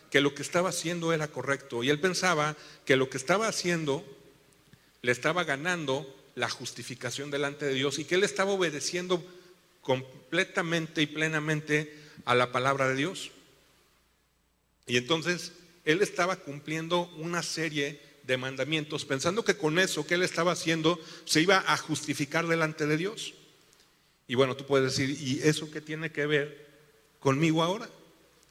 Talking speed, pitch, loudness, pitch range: 155 wpm, 150 Hz, -29 LUFS, 140-175 Hz